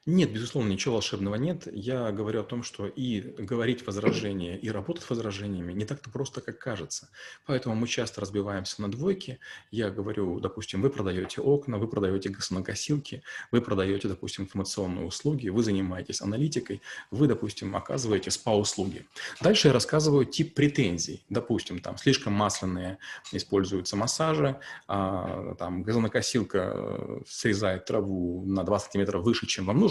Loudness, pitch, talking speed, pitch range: -29 LUFS, 105 Hz, 140 wpm, 95-125 Hz